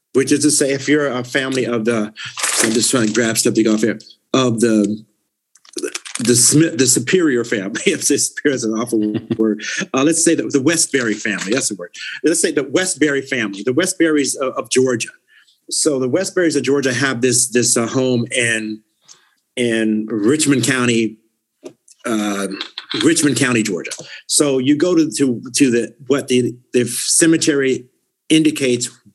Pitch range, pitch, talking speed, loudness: 115-145 Hz, 125 Hz, 170 wpm, -16 LUFS